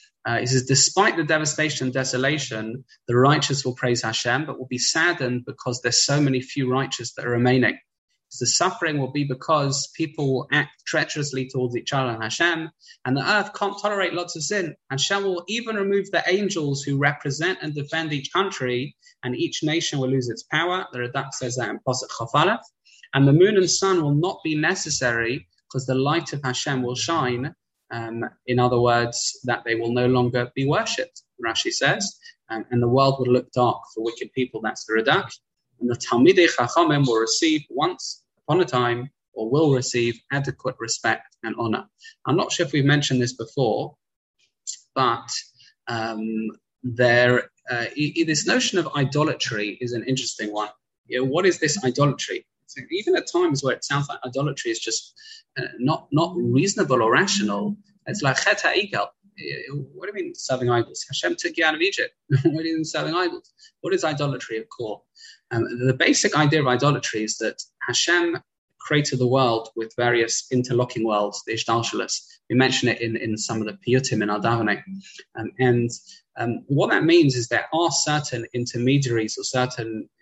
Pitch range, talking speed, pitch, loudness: 120-165 Hz, 185 wpm, 135 Hz, -22 LUFS